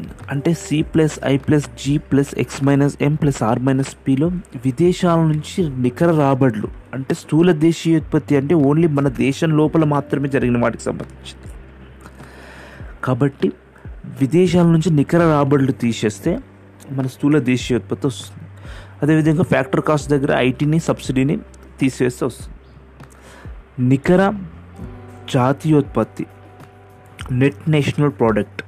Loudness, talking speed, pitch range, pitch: -18 LUFS, 115 wpm, 115-155 Hz, 135 Hz